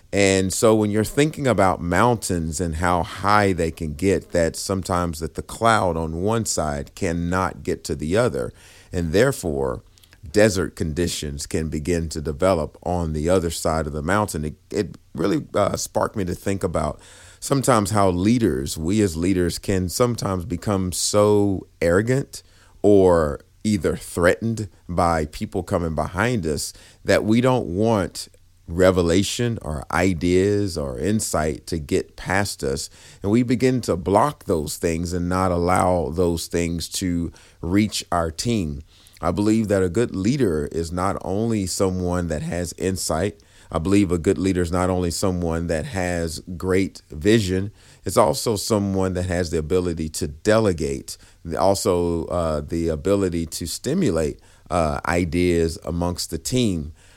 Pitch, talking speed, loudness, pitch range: 90 Hz, 150 wpm, -22 LUFS, 85-100 Hz